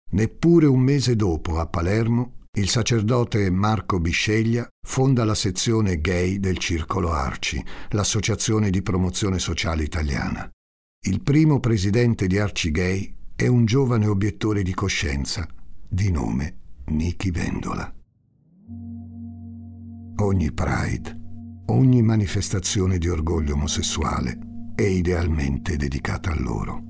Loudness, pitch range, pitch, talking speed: -22 LUFS, 85-115 Hz, 100 Hz, 110 wpm